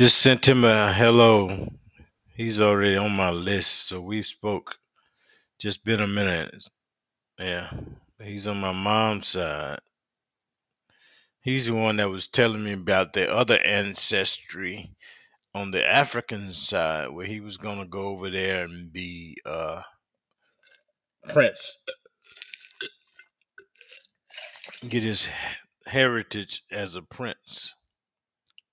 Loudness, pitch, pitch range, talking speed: -24 LUFS, 105 Hz, 100-125 Hz, 115 wpm